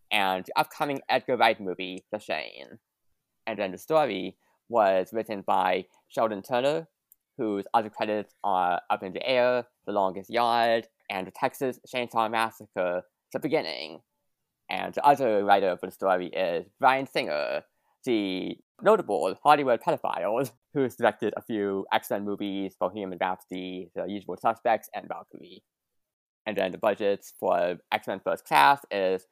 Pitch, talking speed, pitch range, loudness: 105 Hz, 150 wpm, 95-115 Hz, -27 LUFS